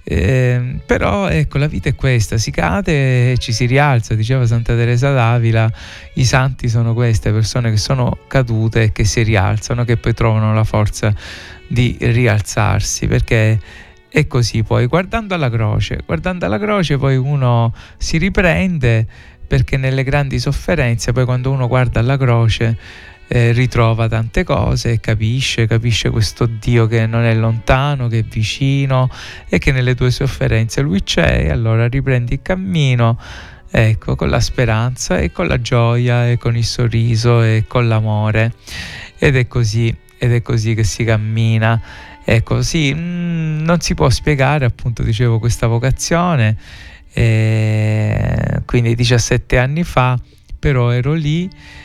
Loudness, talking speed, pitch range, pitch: -15 LUFS, 150 wpm, 110-130 Hz, 120 Hz